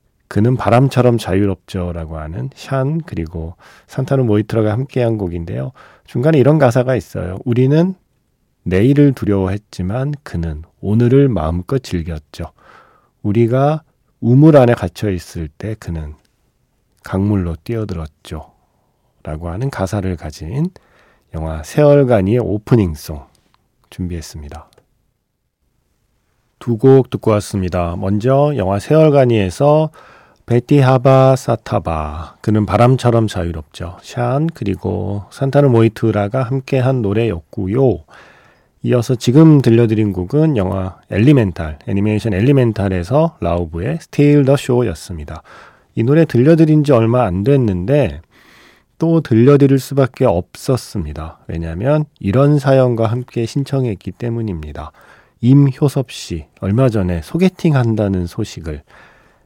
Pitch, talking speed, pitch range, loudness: 115 Hz, 275 characters per minute, 90-135 Hz, -15 LUFS